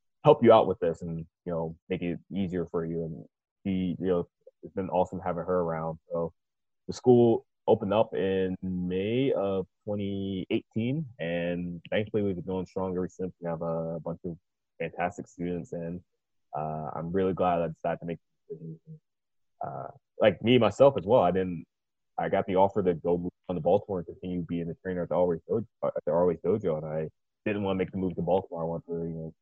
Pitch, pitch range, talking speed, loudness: 90 Hz, 85-95 Hz, 205 wpm, -29 LUFS